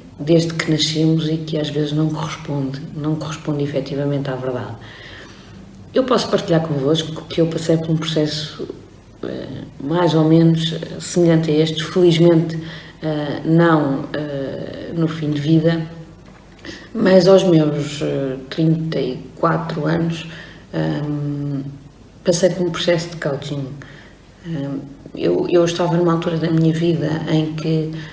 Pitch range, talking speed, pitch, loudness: 145-165 Hz, 120 wpm, 160 Hz, -18 LUFS